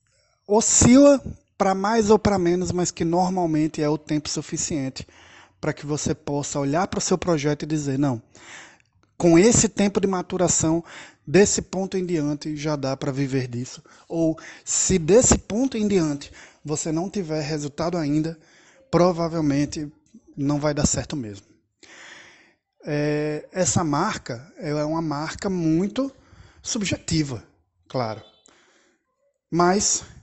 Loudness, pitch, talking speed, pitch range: -22 LUFS, 160 Hz, 130 wpm, 145-185 Hz